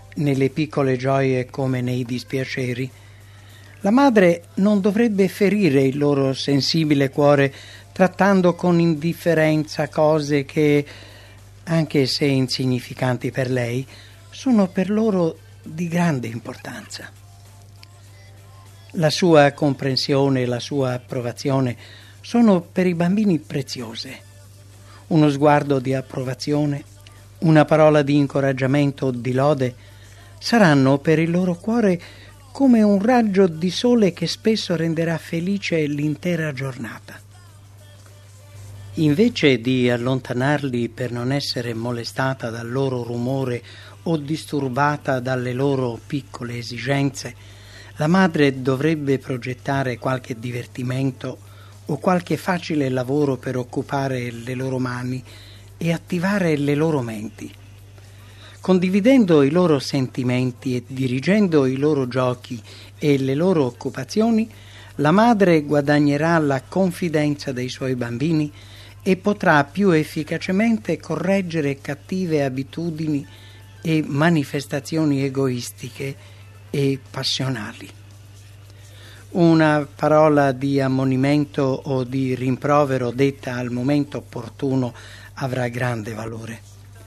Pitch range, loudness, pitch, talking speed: 120-155 Hz, -20 LUFS, 135 Hz, 105 wpm